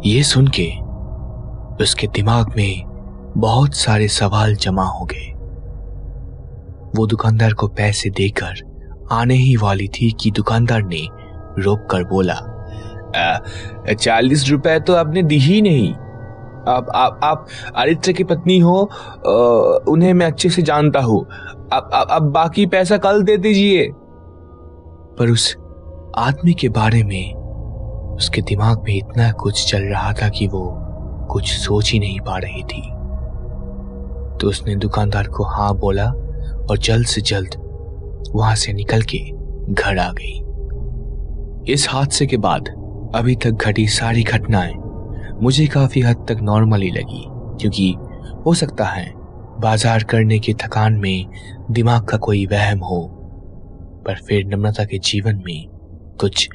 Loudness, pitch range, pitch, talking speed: -16 LUFS, 95-120 Hz, 105 Hz, 135 wpm